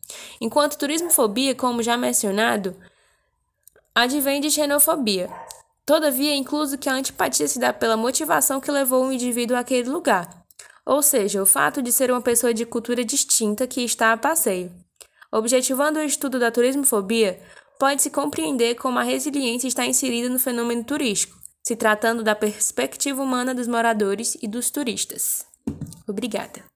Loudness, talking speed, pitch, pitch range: -21 LUFS, 145 wpm, 250 Hz, 225-280 Hz